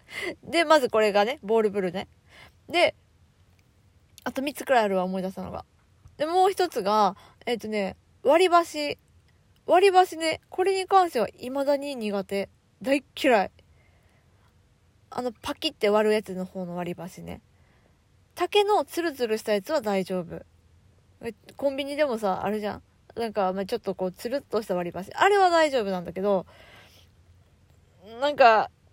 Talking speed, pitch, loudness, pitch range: 285 characters per minute, 215 Hz, -25 LUFS, 190-295 Hz